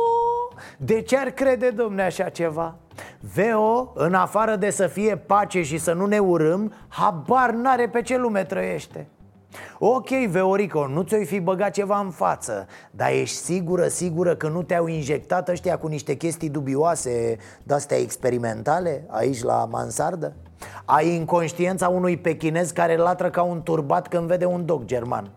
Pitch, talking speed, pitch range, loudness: 175 Hz, 155 wpm, 155-205 Hz, -23 LUFS